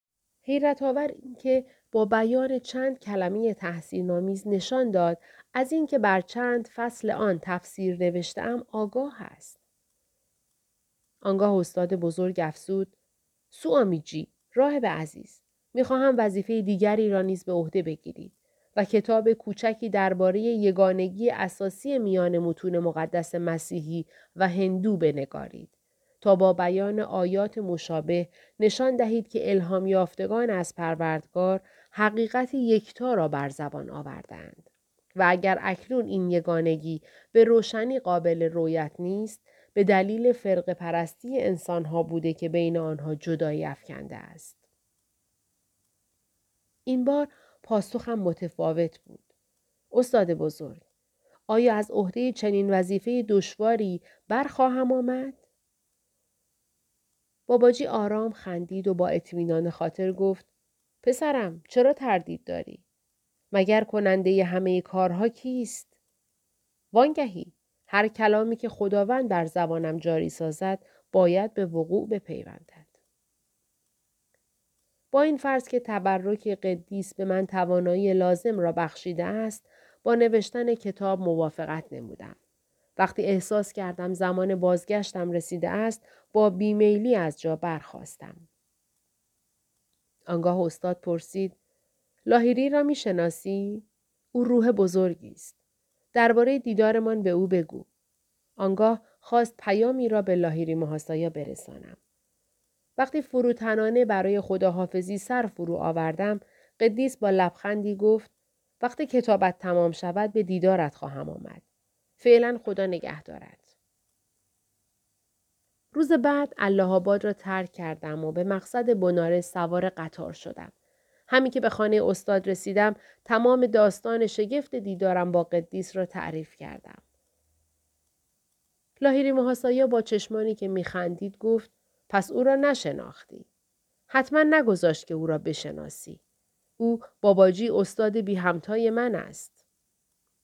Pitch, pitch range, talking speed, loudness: 195 Hz, 175-230 Hz, 115 wpm, -26 LUFS